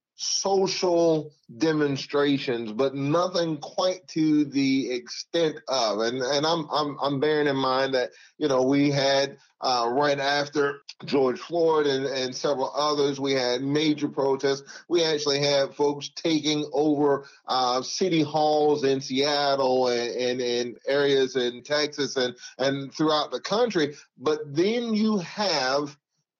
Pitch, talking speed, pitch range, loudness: 145 Hz, 135 wpm, 135-155 Hz, -25 LUFS